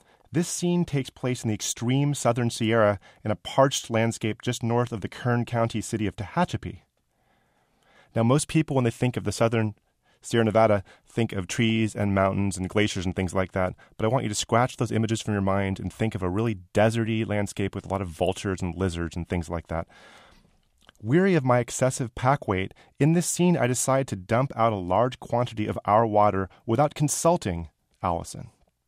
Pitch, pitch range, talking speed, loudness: 110 Hz, 100-125 Hz, 200 wpm, -25 LUFS